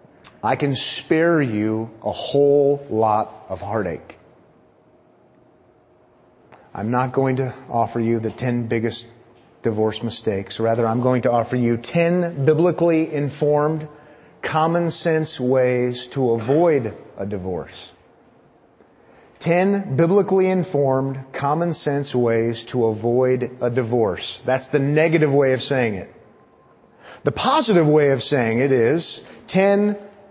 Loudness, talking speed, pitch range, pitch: -20 LUFS, 120 wpm, 115-155 Hz, 130 Hz